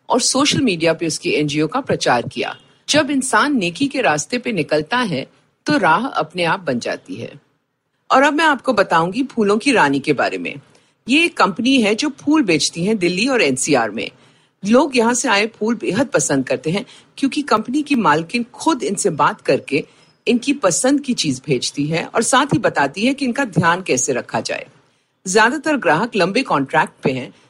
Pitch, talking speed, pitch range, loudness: 230 Hz, 190 wpm, 165-275 Hz, -17 LUFS